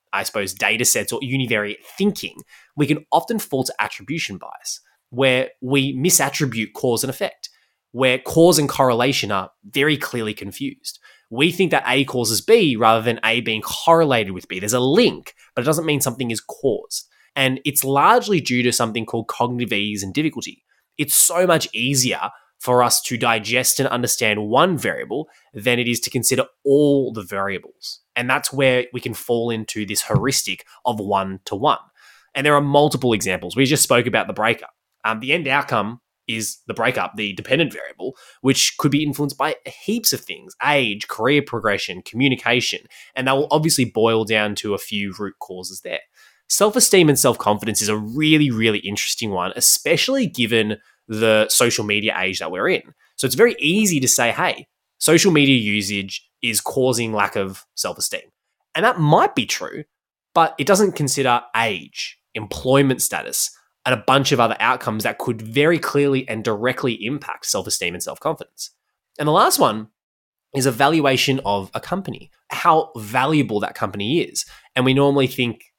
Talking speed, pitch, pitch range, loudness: 175 wpm, 125 Hz, 110-145 Hz, -19 LUFS